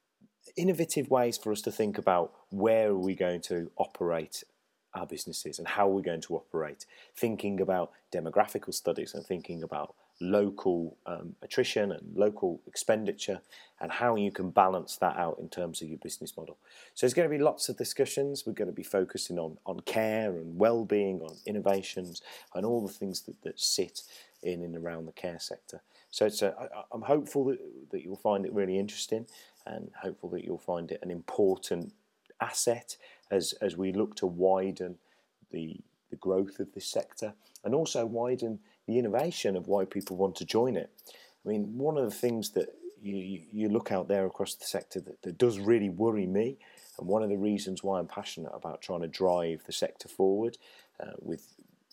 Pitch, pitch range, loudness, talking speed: 100 Hz, 95-115 Hz, -32 LUFS, 190 wpm